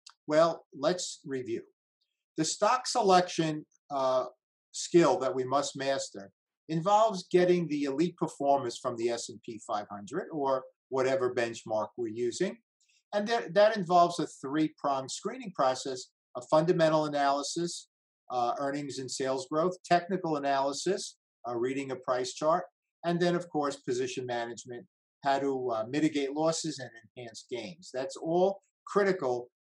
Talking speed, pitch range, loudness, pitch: 135 wpm, 130-180 Hz, -30 LUFS, 155 Hz